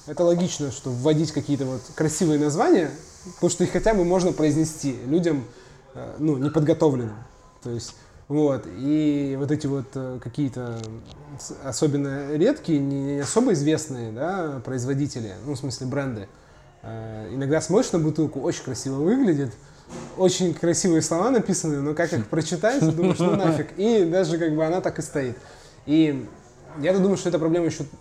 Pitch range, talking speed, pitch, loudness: 135-165 Hz, 150 wpm, 150 Hz, -23 LUFS